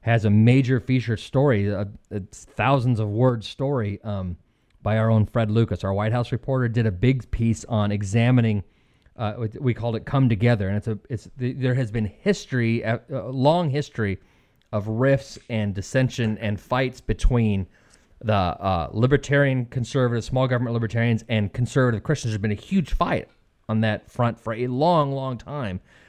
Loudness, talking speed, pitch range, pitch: -23 LUFS, 170 wpm, 105-130 Hz, 115 Hz